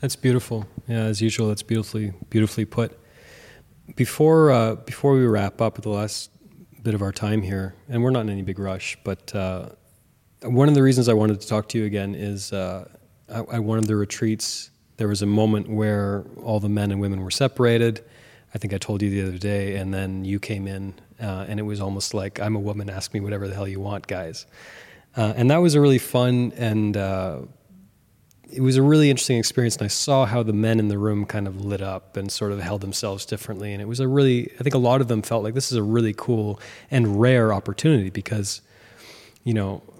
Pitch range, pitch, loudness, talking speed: 100-120 Hz, 110 Hz, -22 LUFS, 225 wpm